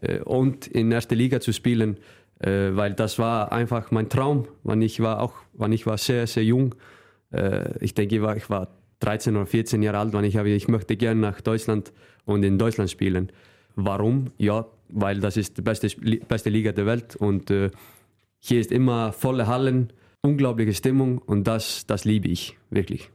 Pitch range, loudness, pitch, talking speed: 105-120 Hz, -24 LUFS, 110 Hz, 175 wpm